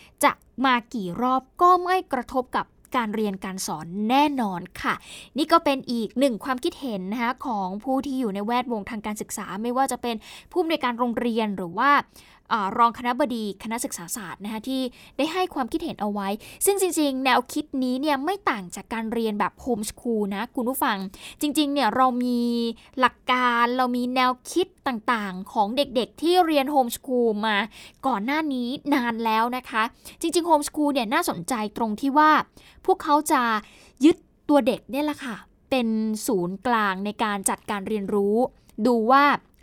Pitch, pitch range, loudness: 245 Hz, 220-280 Hz, -24 LUFS